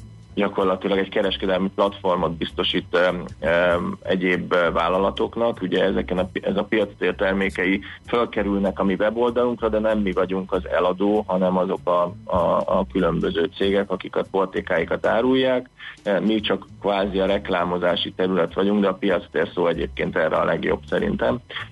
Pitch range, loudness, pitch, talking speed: 95-105 Hz, -22 LUFS, 95 Hz, 145 wpm